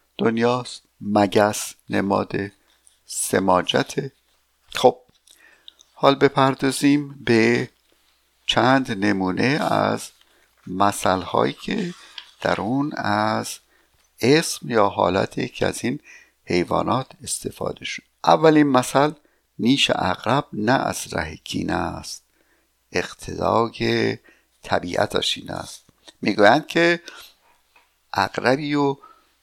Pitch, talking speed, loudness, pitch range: 120 Hz, 90 wpm, -21 LUFS, 105-140 Hz